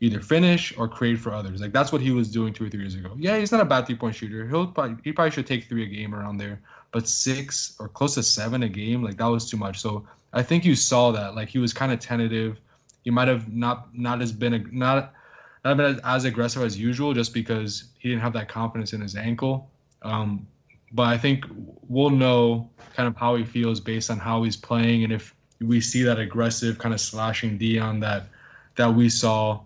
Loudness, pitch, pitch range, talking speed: -24 LUFS, 115 Hz, 110-125 Hz, 235 wpm